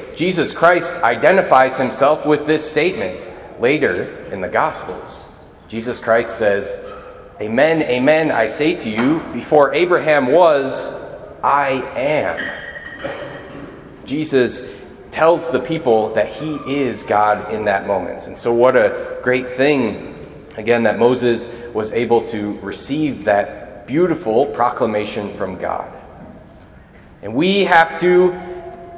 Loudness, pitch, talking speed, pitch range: -17 LUFS, 125 Hz, 120 wpm, 115-160 Hz